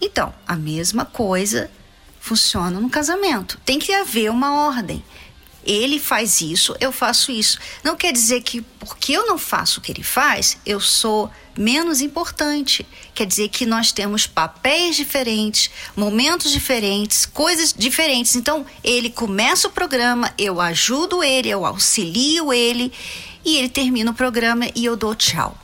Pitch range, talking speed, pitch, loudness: 215-290 Hz, 150 wpm, 245 Hz, -17 LUFS